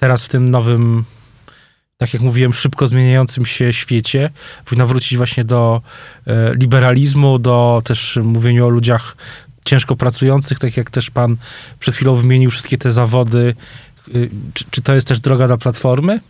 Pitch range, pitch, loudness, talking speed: 120-130 Hz, 125 Hz, -14 LUFS, 150 wpm